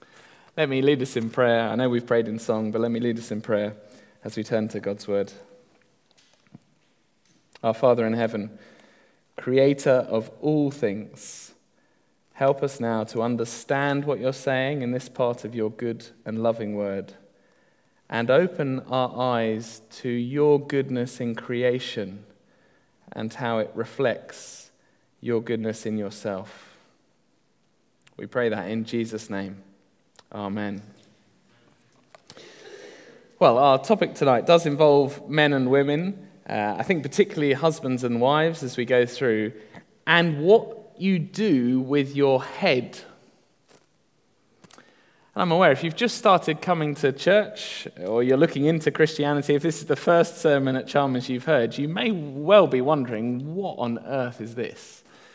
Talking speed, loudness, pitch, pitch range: 145 wpm, -24 LUFS, 125 Hz, 110-145 Hz